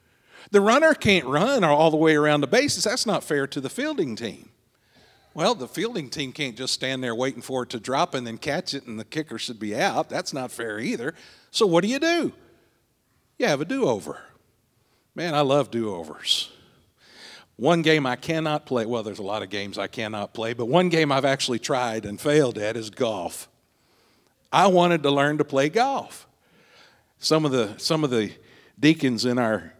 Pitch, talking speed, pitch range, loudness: 135 Hz, 195 wpm, 115-155 Hz, -23 LUFS